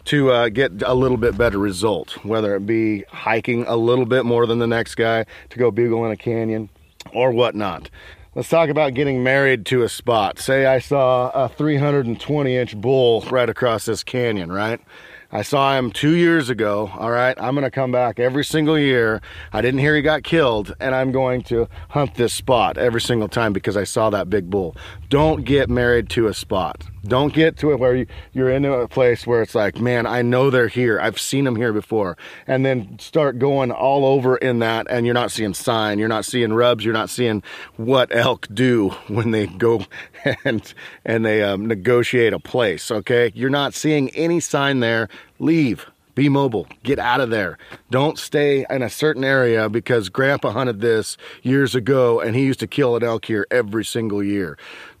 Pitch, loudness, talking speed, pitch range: 120 Hz, -19 LUFS, 200 wpm, 110-135 Hz